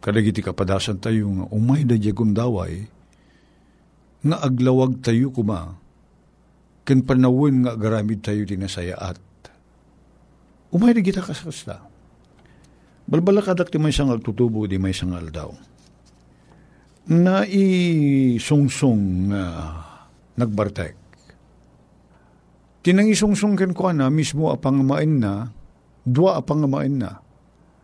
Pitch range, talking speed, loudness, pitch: 95-145 Hz, 105 wpm, -20 LUFS, 115 Hz